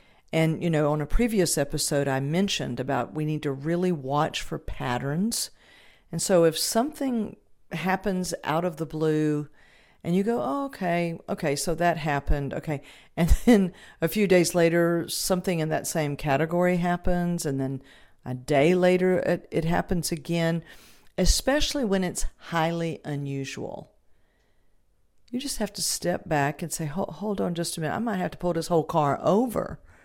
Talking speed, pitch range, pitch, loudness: 170 wpm, 150-180 Hz, 170 Hz, -26 LUFS